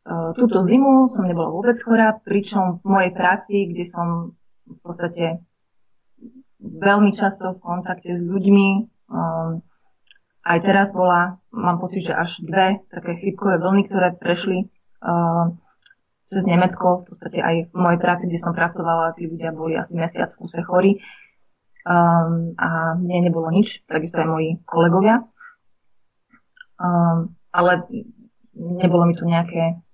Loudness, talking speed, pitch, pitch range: -20 LUFS, 135 wpm, 180 Hz, 170-195 Hz